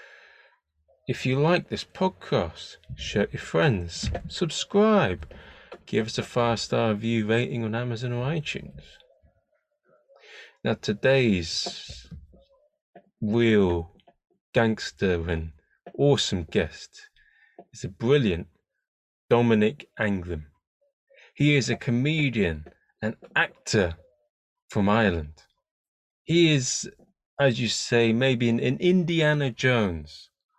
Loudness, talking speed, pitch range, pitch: -25 LUFS, 100 wpm, 105-160 Hz, 120 Hz